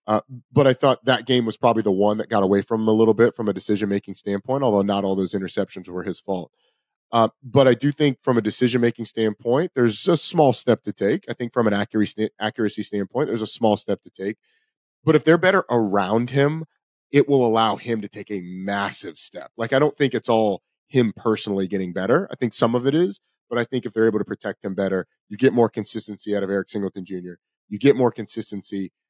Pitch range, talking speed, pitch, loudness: 100-125 Hz, 245 wpm, 110 Hz, -21 LUFS